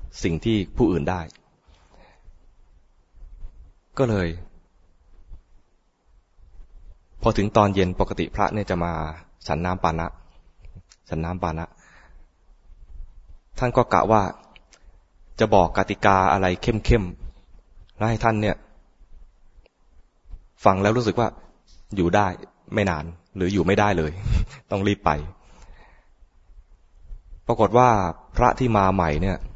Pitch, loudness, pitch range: 90 Hz, -22 LUFS, 80-100 Hz